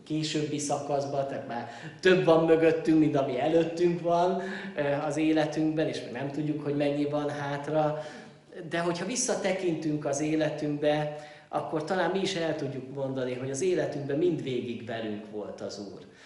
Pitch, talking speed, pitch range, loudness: 150 Hz, 150 wpm, 140-165 Hz, -29 LUFS